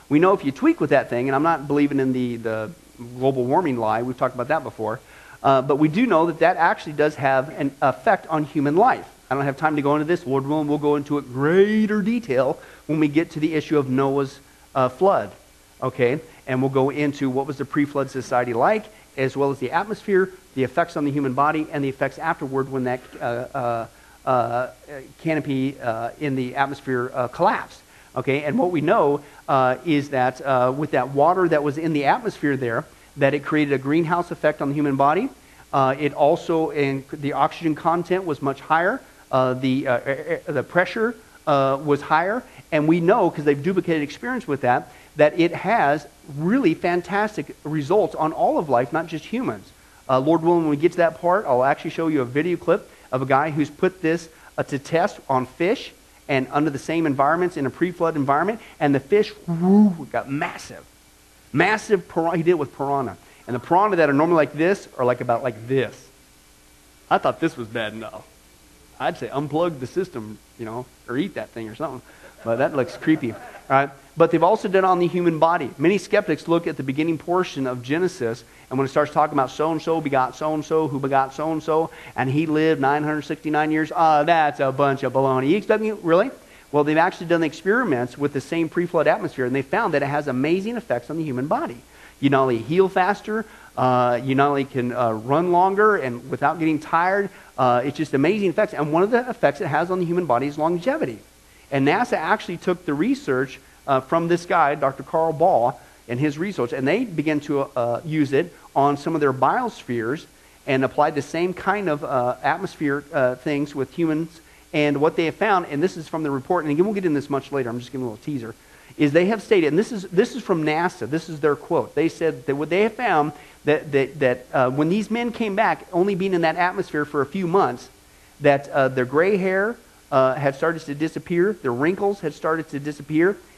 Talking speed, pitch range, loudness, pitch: 220 wpm, 135-170 Hz, -22 LUFS, 150 Hz